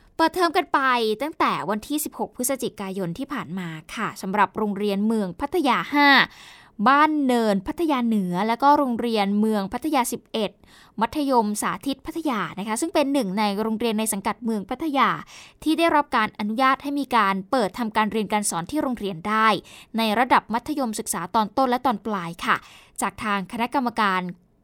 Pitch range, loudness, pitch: 210-275 Hz, -23 LUFS, 230 Hz